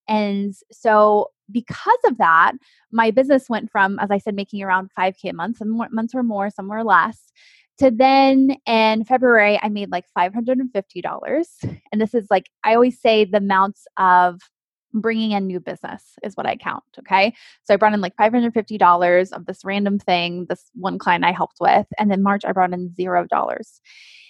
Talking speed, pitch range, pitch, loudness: 205 wpm, 190-230 Hz, 210 Hz, -18 LUFS